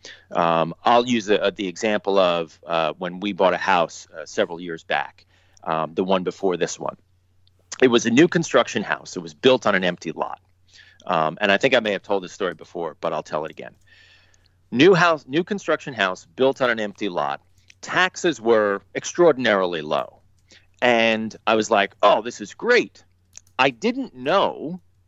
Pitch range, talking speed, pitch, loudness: 90-125 Hz, 185 wpm, 100 Hz, -21 LUFS